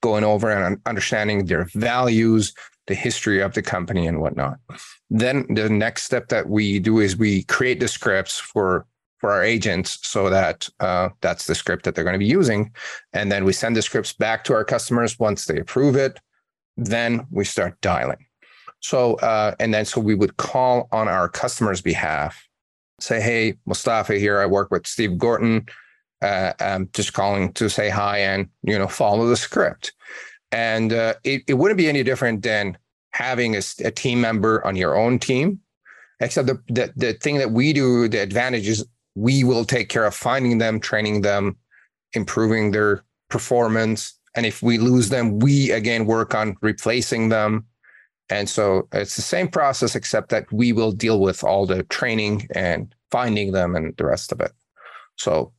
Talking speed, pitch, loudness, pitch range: 180 wpm, 110 Hz, -21 LUFS, 105-120 Hz